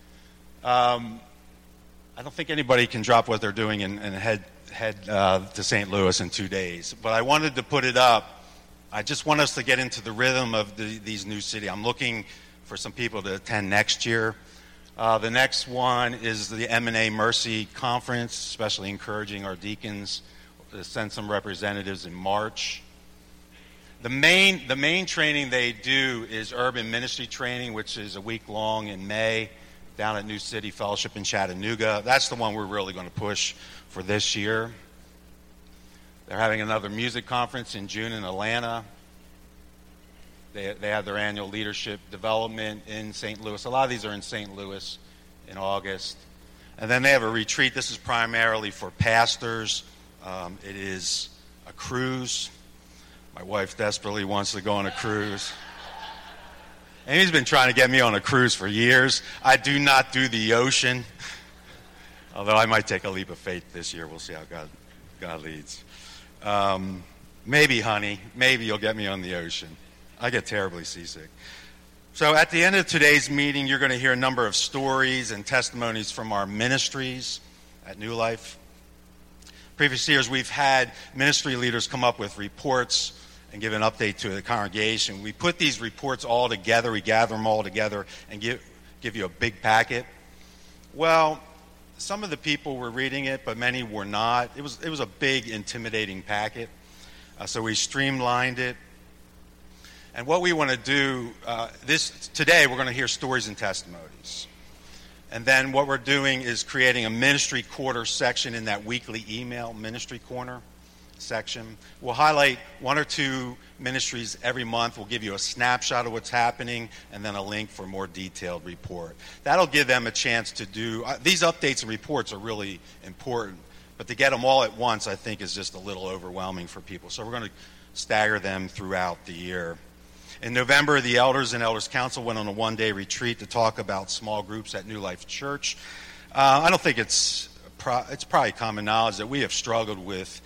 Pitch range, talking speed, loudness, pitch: 90-125 Hz, 180 wpm, -24 LUFS, 110 Hz